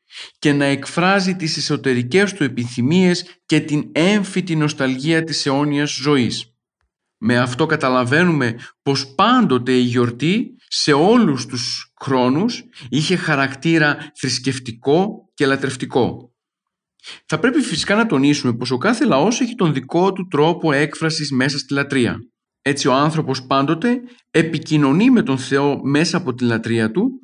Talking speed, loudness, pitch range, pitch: 135 wpm, -18 LUFS, 130-175 Hz, 145 Hz